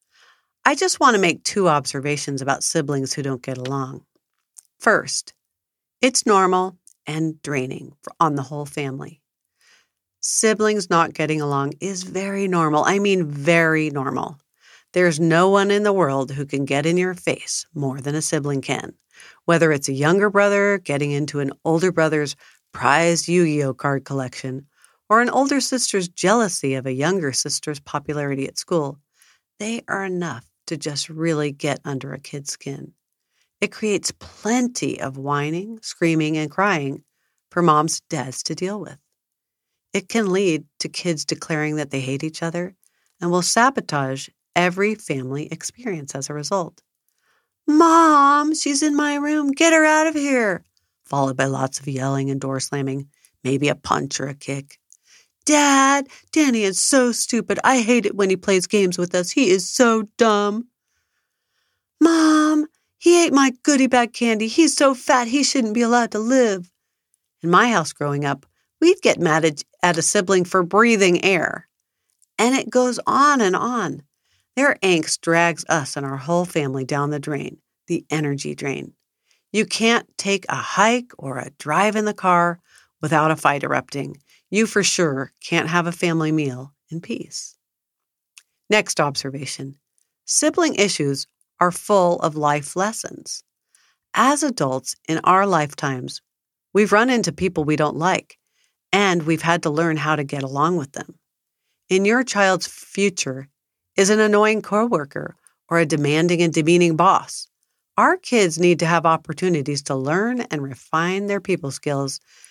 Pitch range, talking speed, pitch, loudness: 145-205 Hz, 160 wpm, 170 Hz, -20 LUFS